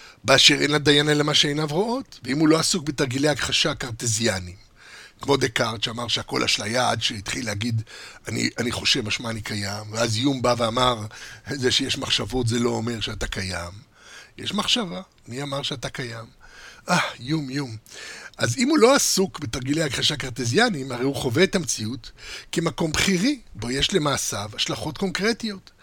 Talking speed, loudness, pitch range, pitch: 165 wpm, -22 LUFS, 115-155 Hz, 135 Hz